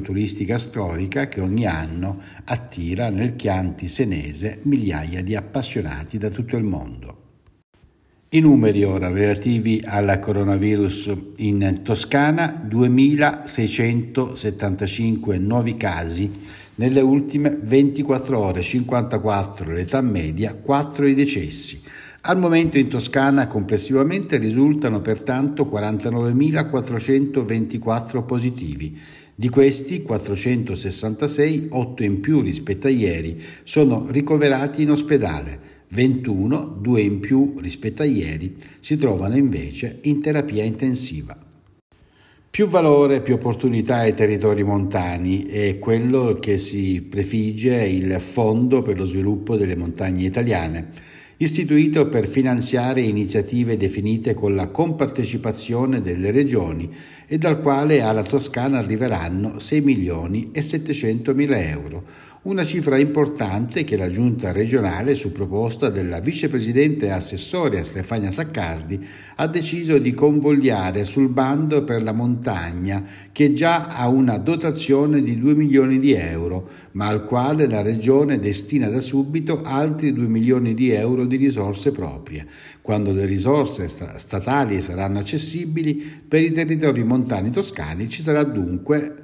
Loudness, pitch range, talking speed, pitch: -20 LUFS, 100-140 Hz, 120 wpm, 115 Hz